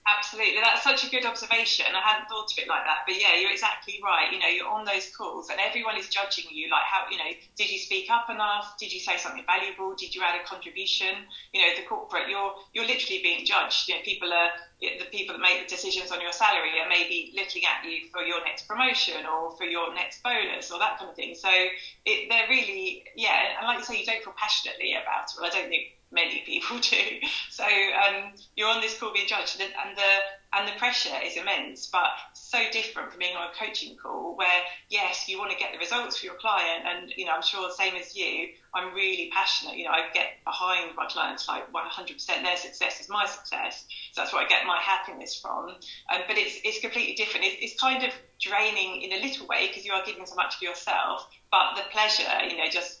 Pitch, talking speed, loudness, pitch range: 200 Hz, 240 wpm, -26 LUFS, 180-235 Hz